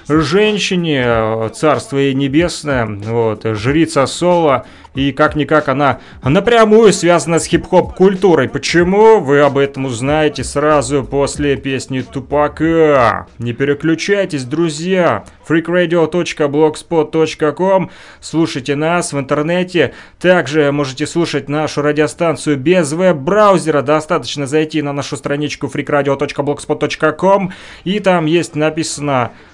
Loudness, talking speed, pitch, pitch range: -14 LUFS, 100 wpm, 150 Hz, 140-170 Hz